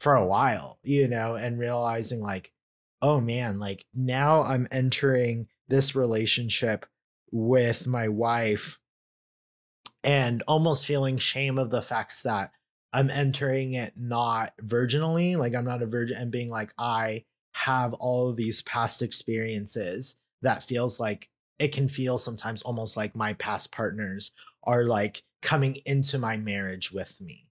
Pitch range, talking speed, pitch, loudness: 115-135 Hz, 145 wpm, 120 Hz, -27 LUFS